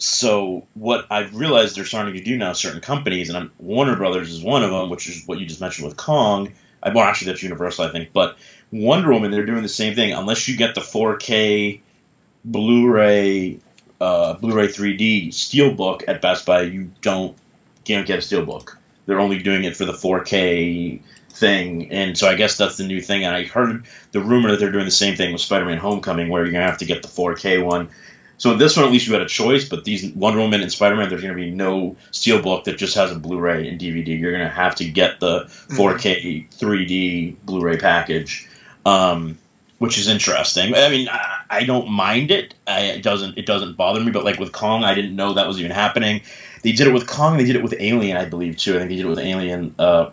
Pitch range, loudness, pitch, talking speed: 90-110 Hz, -19 LUFS, 100 Hz, 225 wpm